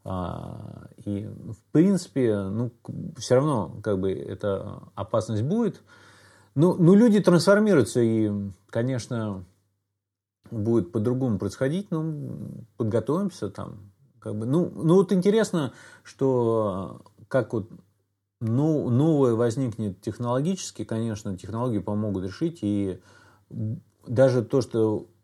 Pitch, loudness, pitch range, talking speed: 115 Hz, -25 LUFS, 100-140 Hz, 100 wpm